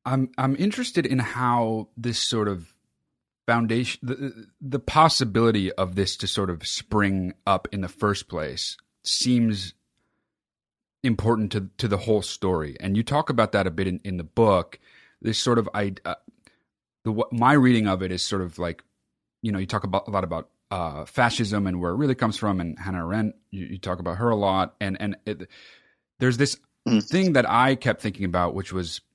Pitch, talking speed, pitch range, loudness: 105 Hz, 195 wpm, 95-120 Hz, -24 LUFS